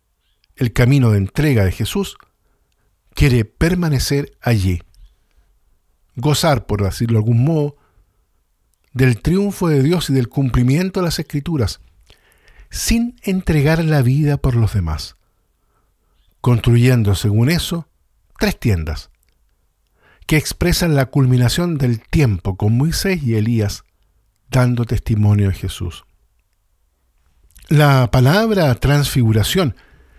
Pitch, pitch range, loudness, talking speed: 120 Hz, 95-145 Hz, -17 LUFS, 105 wpm